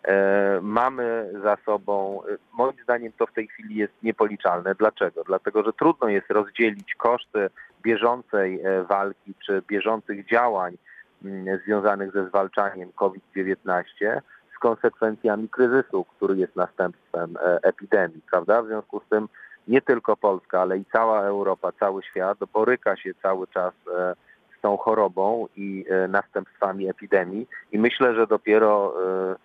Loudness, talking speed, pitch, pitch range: -24 LUFS, 125 wpm, 100 Hz, 95-110 Hz